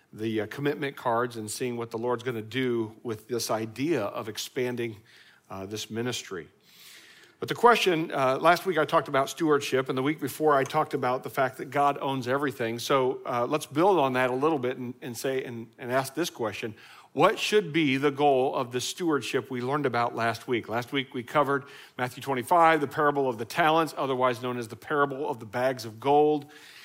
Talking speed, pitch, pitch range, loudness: 205 wpm, 130 Hz, 120-145 Hz, -27 LUFS